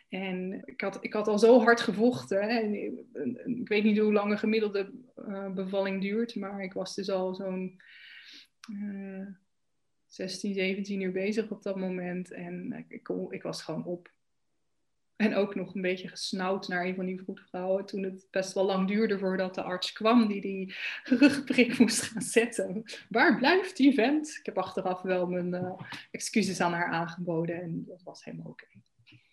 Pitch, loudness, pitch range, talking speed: 195 Hz, -29 LUFS, 185-225 Hz, 180 wpm